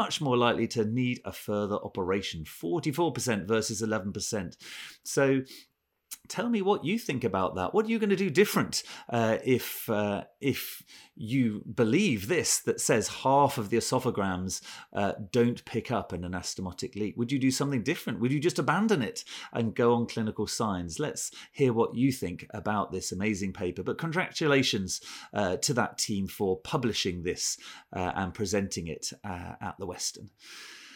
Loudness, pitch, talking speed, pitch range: -29 LUFS, 115 Hz, 170 wpm, 100-135 Hz